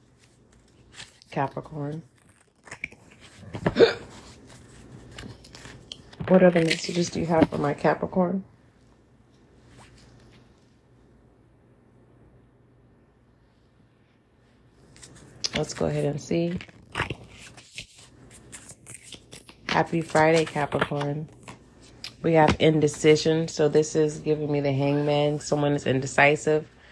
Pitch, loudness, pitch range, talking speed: 145 Hz, -24 LUFS, 125-155 Hz, 70 wpm